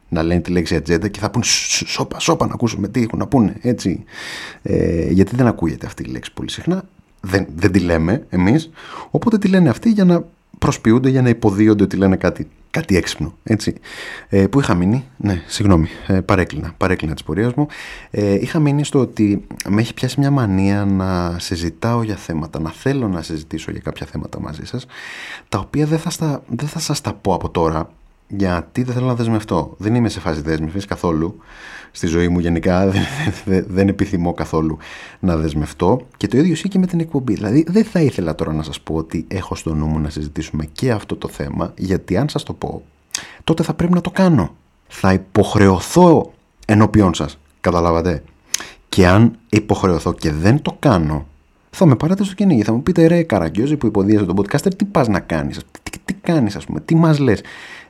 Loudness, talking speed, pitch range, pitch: -17 LUFS, 200 wpm, 85-135 Hz, 100 Hz